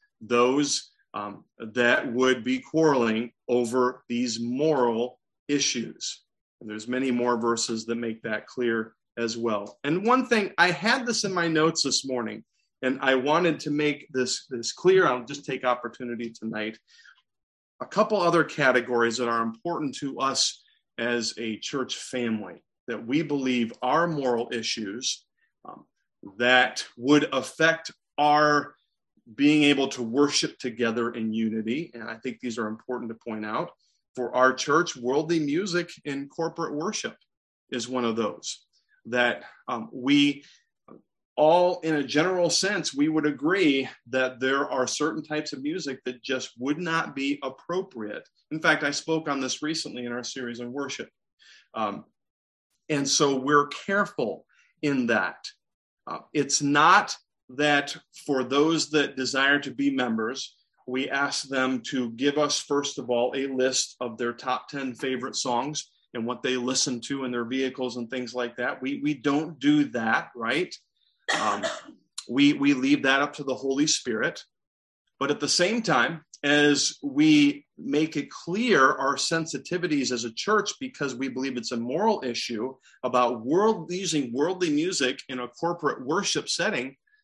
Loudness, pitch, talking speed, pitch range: -26 LUFS, 135 Hz, 155 wpm, 125-155 Hz